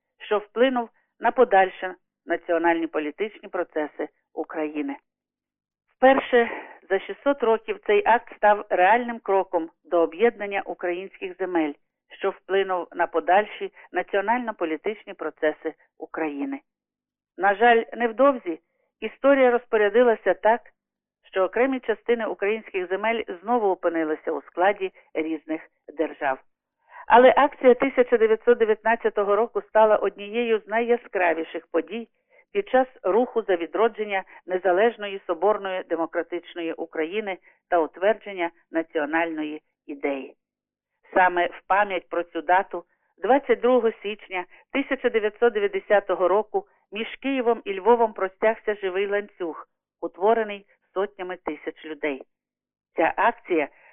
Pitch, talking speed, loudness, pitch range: 200 Hz, 100 wpm, -24 LUFS, 170-235 Hz